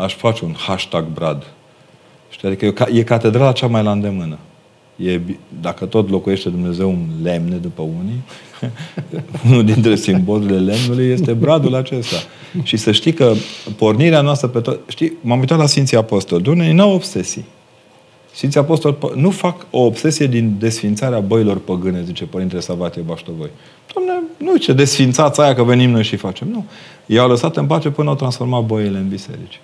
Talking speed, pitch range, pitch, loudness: 165 wpm, 95-145 Hz, 115 Hz, -15 LUFS